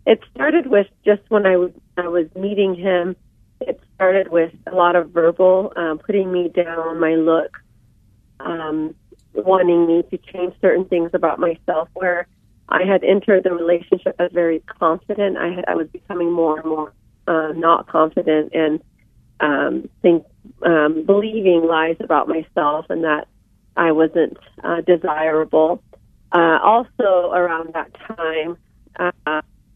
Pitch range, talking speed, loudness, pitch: 160-185 Hz, 145 wpm, -18 LUFS, 170 Hz